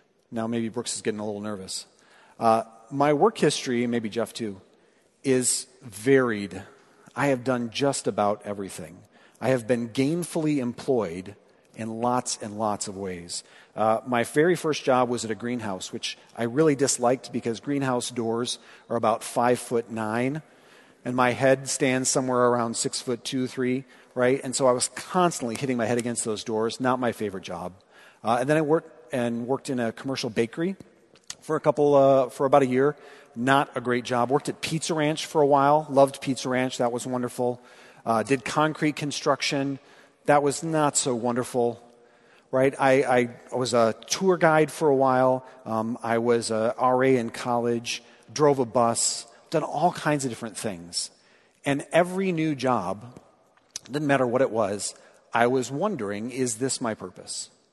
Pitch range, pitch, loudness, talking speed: 115-140 Hz, 125 Hz, -25 LUFS, 175 wpm